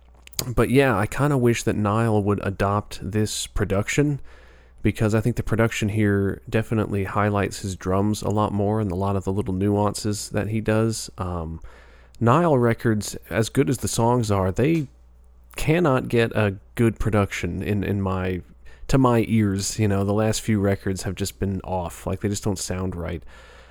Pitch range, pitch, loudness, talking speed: 95-115 Hz, 105 Hz, -23 LUFS, 180 wpm